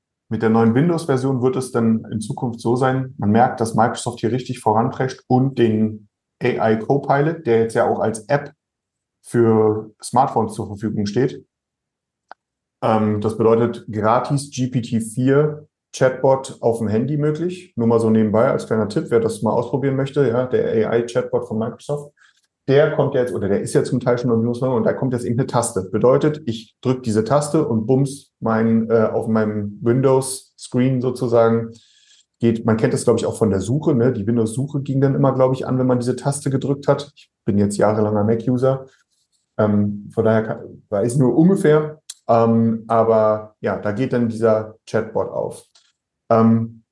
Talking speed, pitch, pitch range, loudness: 175 wpm, 120 Hz, 110-135 Hz, -19 LUFS